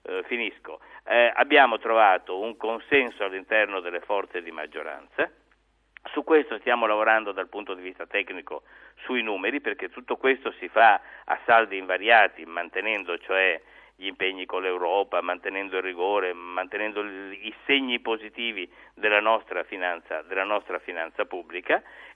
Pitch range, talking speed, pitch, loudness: 95-120 Hz, 140 wpm, 105 Hz, -25 LUFS